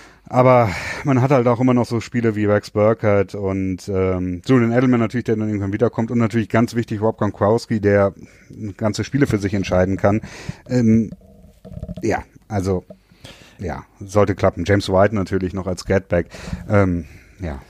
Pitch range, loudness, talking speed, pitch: 95-115 Hz, -19 LUFS, 165 wpm, 105 Hz